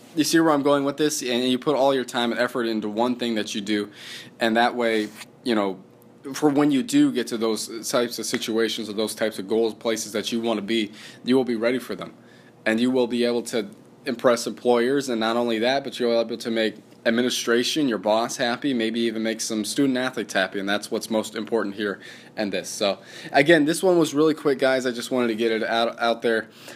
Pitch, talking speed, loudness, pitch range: 115 Hz, 245 wpm, -23 LUFS, 110-130 Hz